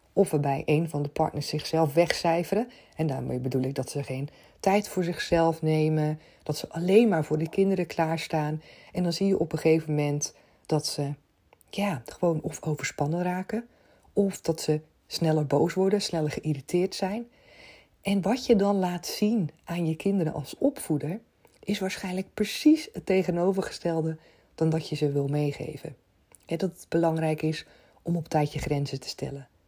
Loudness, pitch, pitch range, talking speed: -28 LUFS, 165 Hz, 150-190 Hz, 170 wpm